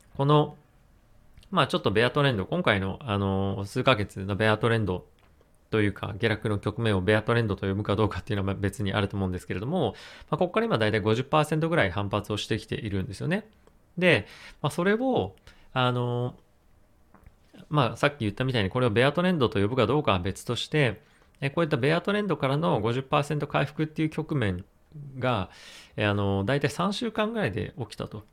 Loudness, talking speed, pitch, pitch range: -27 LUFS, 370 characters per minute, 115 Hz, 100-150 Hz